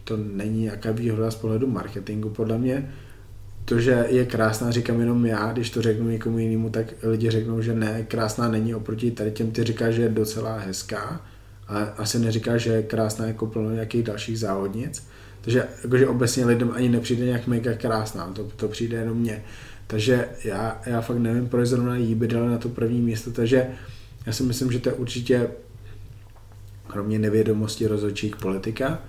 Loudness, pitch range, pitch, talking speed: -24 LUFS, 110-120 Hz, 115 Hz, 185 wpm